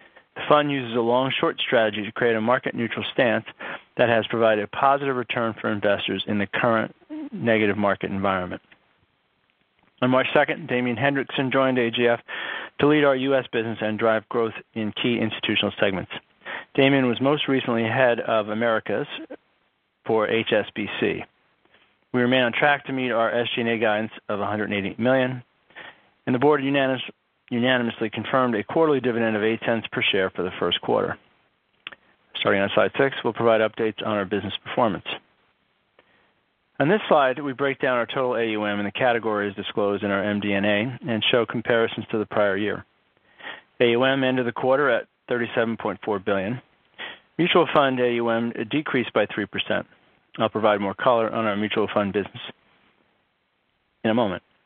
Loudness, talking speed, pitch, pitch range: -23 LUFS, 160 wpm, 115 Hz, 105-130 Hz